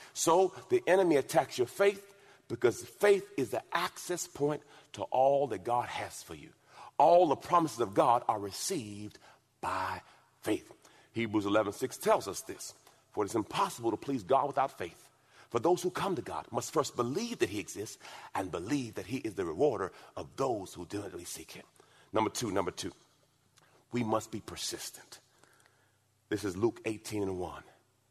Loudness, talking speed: -32 LUFS, 175 wpm